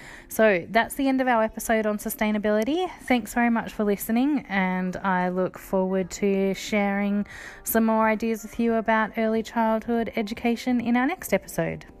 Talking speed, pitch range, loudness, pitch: 165 wpm, 200-235 Hz, -24 LUFS, 220 Hz